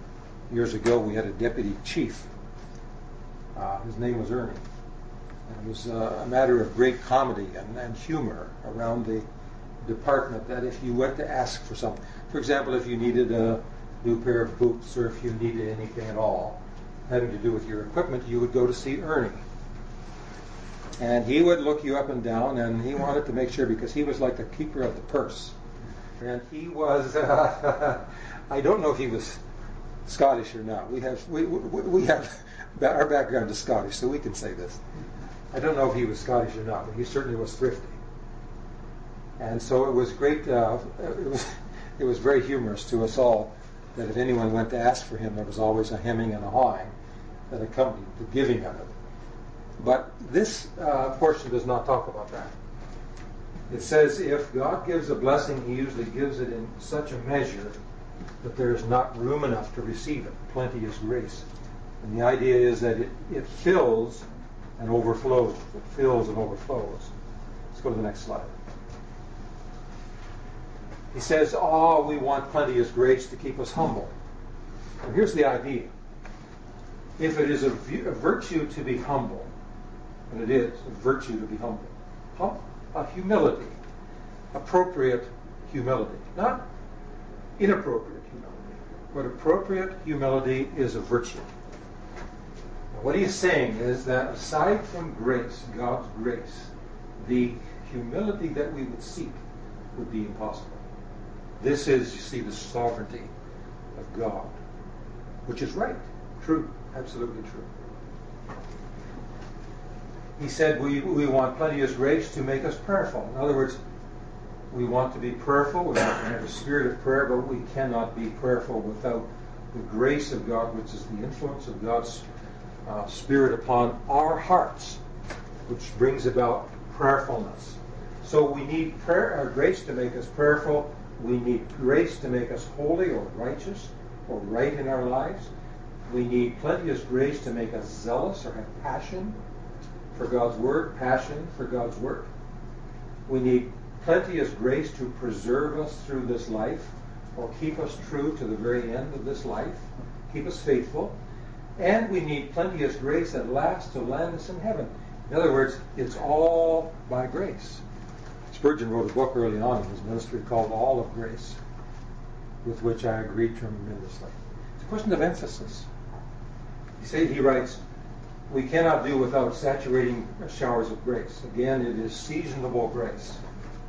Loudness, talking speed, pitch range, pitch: -27 LUFS, 165 wpm, 115-135 Hz, 120 Hz